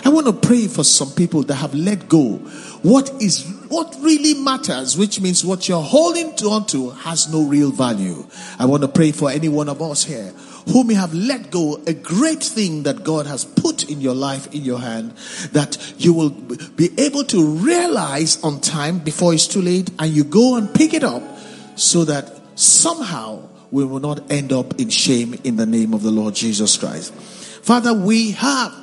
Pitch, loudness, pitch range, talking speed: 165 Hz, -17 LUFS, 145-225 Hz, 200 wpm